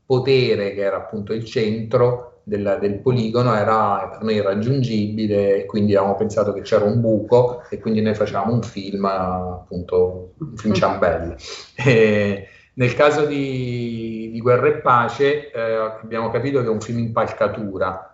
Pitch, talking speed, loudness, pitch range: 110 Hz, 155 wpm, -20 LUFS, 100-120 Hz